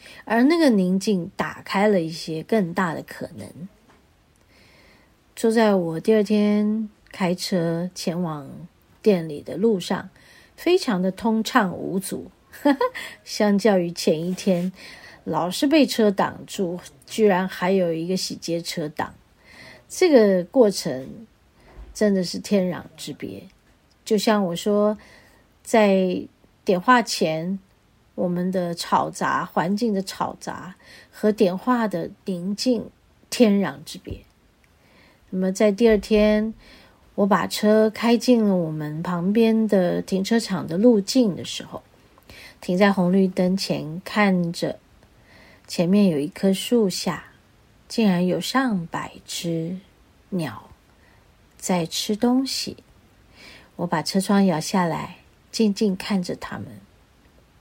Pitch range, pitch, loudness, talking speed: 175-220 Hz, 195 Hz, -22 LUFS, 170 characters per minute